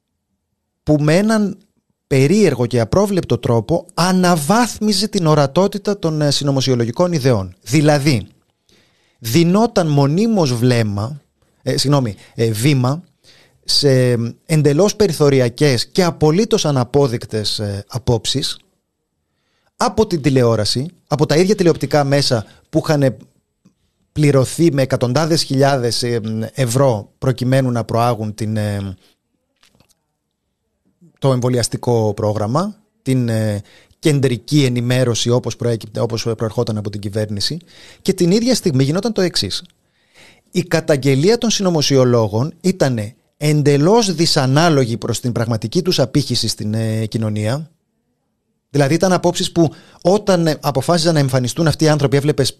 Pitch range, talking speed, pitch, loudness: 120-165 Hz, 110 wpm, 140 Hz, -16 LUFS